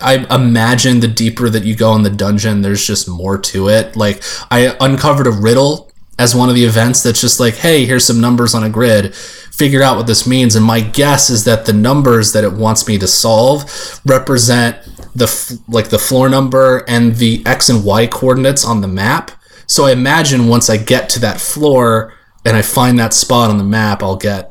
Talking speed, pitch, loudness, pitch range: 215 wpm, 115 Hz, -11 LUFS, 110-130 Hz